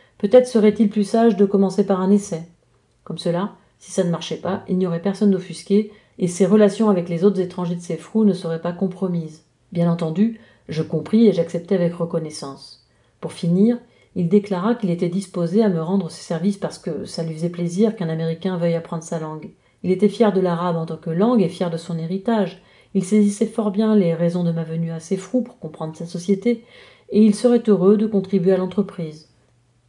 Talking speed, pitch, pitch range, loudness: 210 wpm, 185 Hz, 170-205 Hz, -20 LUFS